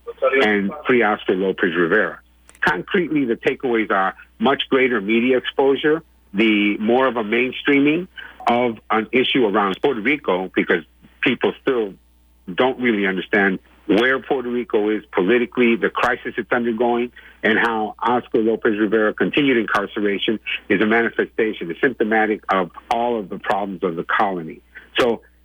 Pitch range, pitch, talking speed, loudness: 105-125 Hz, 115 Hz, 140 wpm, -19 LUFS